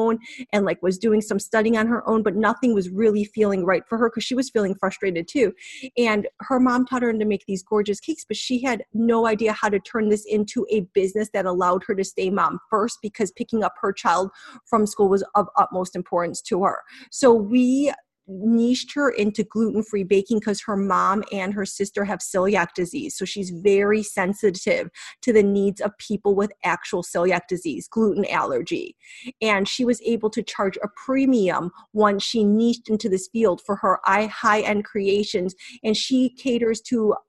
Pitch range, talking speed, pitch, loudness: 195-230 Hz, 195 wpm, 210 Hz, -22 LUFS